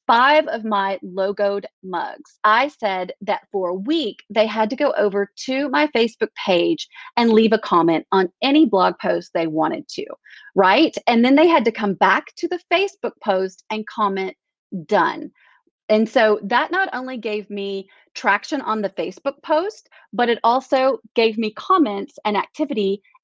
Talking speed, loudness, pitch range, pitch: 170 wpm, -19 LUFS, 200-300 Hz, 225 Hz